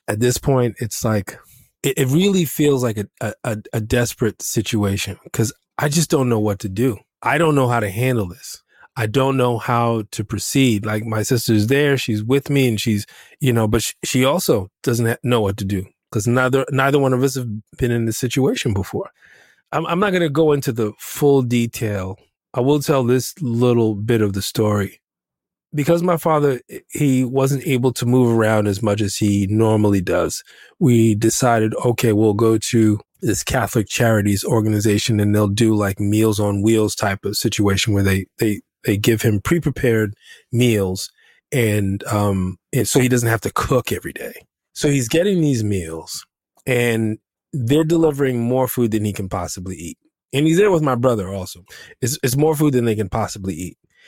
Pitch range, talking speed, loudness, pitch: 105-130 Hz, 190 wpm, -19 LUFS, 115 Hz